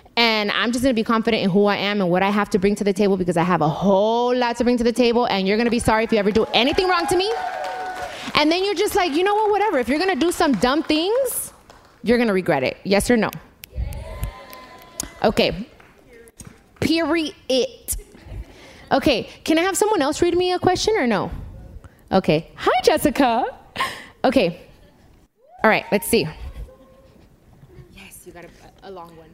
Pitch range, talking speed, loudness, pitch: 200-335 Hz, 195 wpm, -20 LUFS, 240 Hz